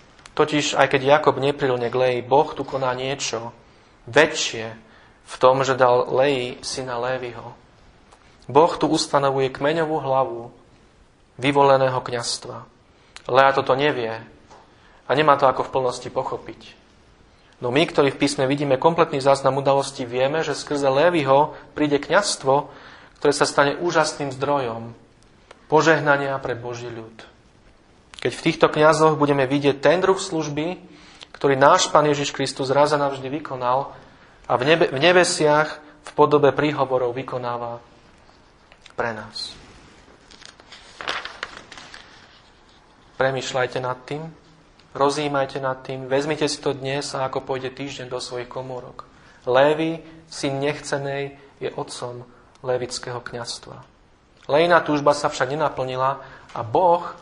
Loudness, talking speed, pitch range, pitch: -21 LUFS, 125 wpm, 125-150 Hz, 135 Hz